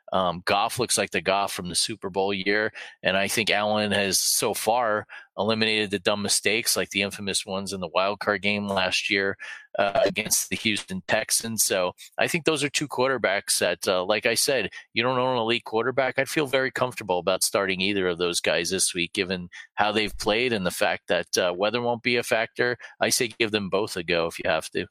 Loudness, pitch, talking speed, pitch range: -24 LUFS, 105 Hz, 225 wpm, 95-115 Hz